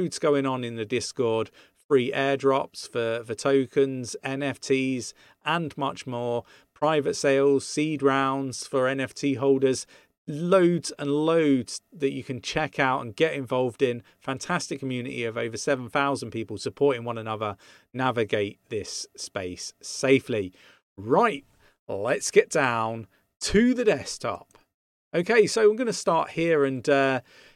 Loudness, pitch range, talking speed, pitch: -26 LUFS, 125-150 Hz, 135 wpm, 135 Hz